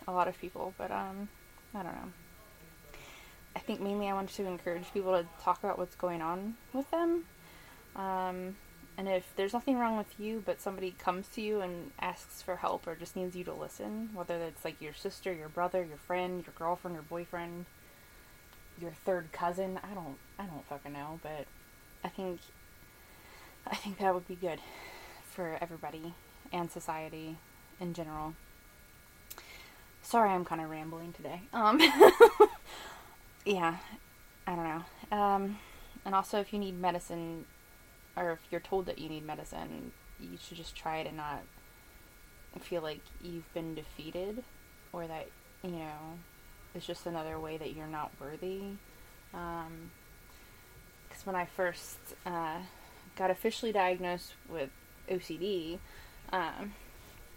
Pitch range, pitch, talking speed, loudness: 160-195 Hz, 175 Hz, 150 wpm, -34 LUFS